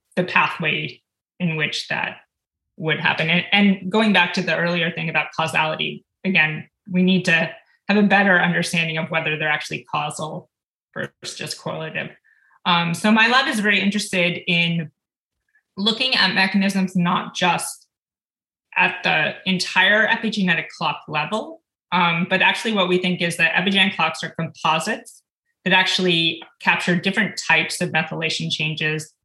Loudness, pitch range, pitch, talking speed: -19 LUFS, 165-200 Hz, 180 Hz, 145 wpm